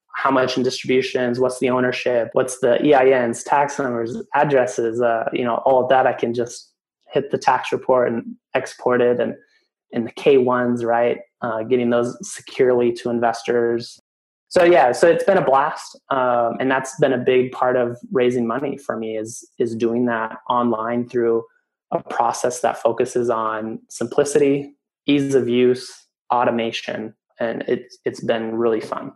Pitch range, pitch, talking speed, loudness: 115-130 Hz, 125 Hz, 170 wpm, -20 LUFS